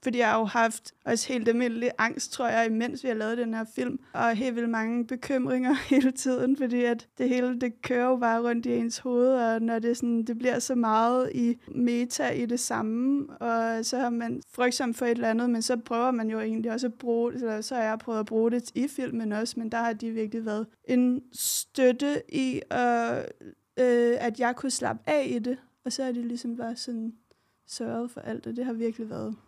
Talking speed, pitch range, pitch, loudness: 230 wpm, 230-250 Hz, 240 Hz, -28 LUFS